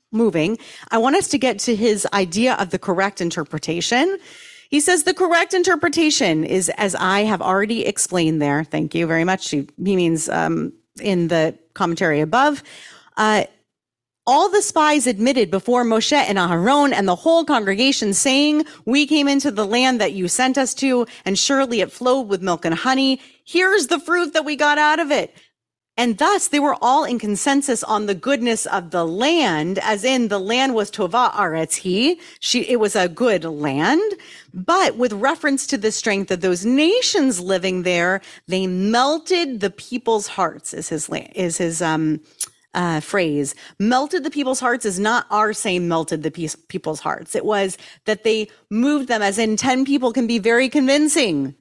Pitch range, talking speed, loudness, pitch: 185-280 Hz, 180 wpm, -19 LUFS, 225 Hz